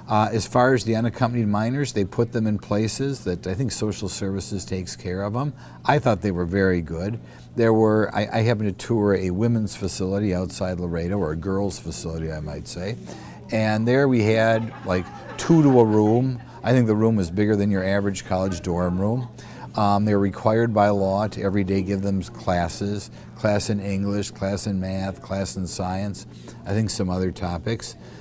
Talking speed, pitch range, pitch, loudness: 195 wpm, 95-115 Hz, 100 Hz, -23 LUFS